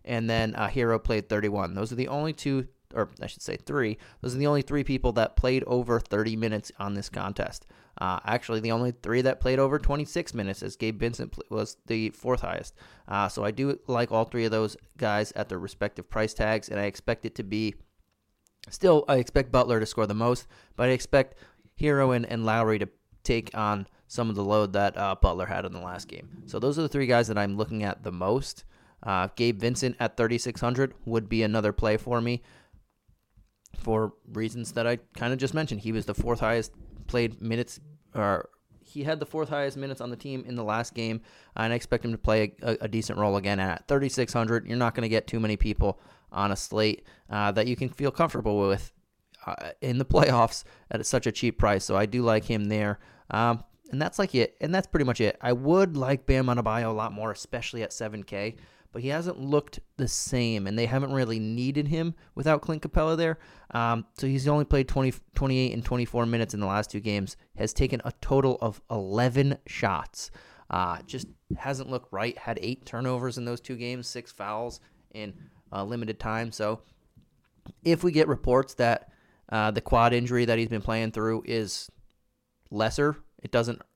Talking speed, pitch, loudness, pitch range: 210 wpm, 115 Hz, -28 LUFS, 110-130 Hz